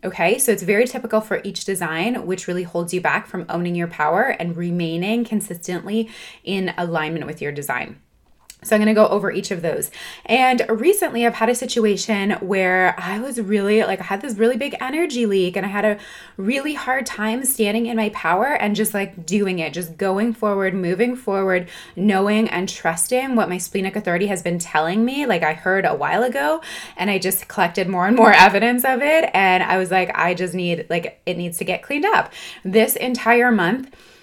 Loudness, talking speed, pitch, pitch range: -19 LUFS, 205 wpm, 200 Hz, 180-235 Hz